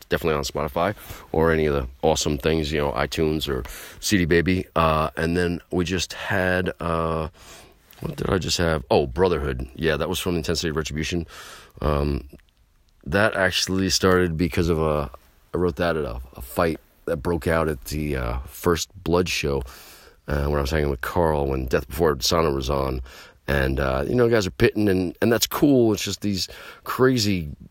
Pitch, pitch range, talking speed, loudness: 80 Hz, 70-90 Hz, 190 wpm, -23 LUFS